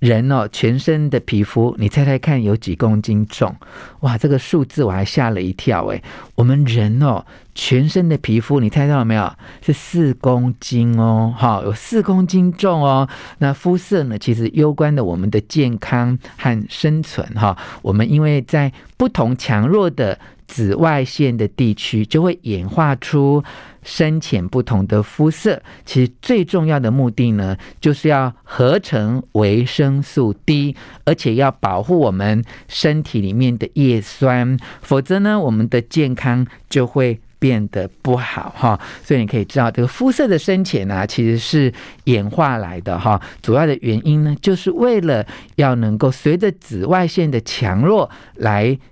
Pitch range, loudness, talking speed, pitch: 110-150 Hz, -17 LUFS, 240 characters per minute, 130 Hz